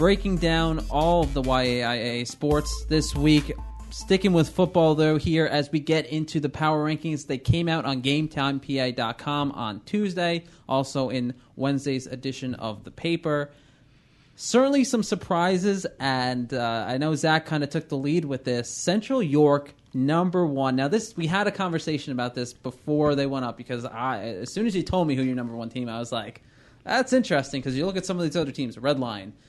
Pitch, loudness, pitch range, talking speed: 145 Hz, -25 LUFS, 130-165 Hz, 195 wpm